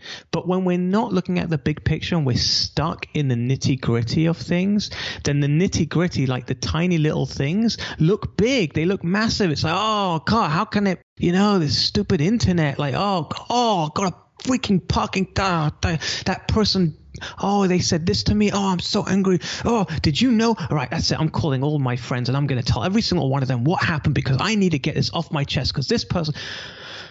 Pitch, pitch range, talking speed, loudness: 170 Hz, 145-195 Hz, 220 wpm, -21 LUFS